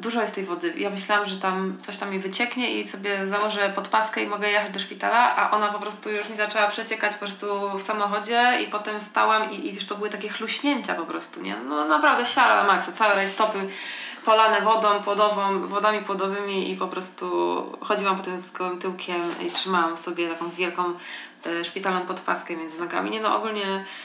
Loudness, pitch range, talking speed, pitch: -24 LUFS, 185-210 Hz, 195 wpm, 200 Hz